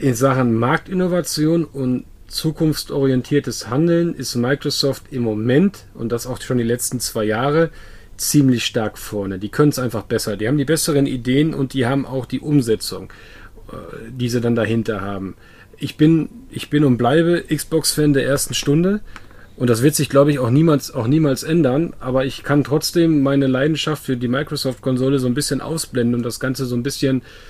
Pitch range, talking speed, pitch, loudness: 120-150 Hz, 180 wpm, 135 Hz, -18 LUFS